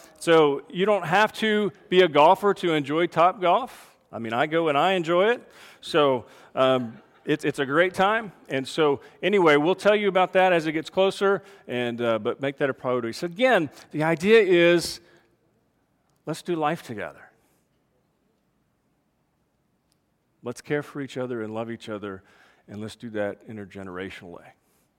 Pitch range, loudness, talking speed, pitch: 125-185 Hz, -23 LUFS, 165 wpm, 155 Hz